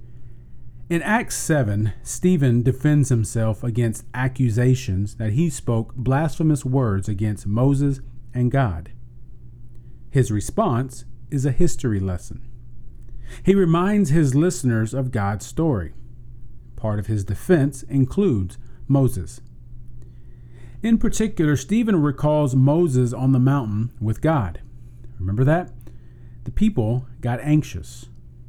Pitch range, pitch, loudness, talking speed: 115-140 Hz, 120 Hz, -21 LUFS, 110 wpm